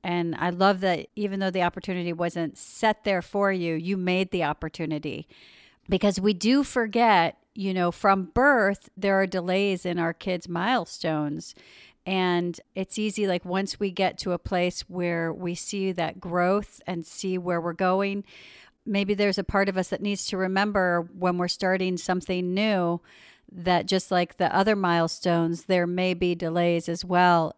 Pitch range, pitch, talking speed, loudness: 175-195 Hz, 185 Hz, 170 wpm, -26 LUFS